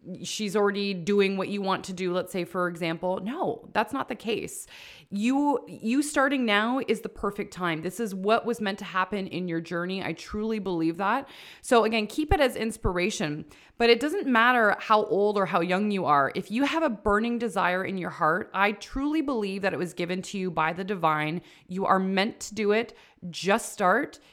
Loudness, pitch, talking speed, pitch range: -26 LUFS, 200 Hz, 210 wpm, 180-225 Hz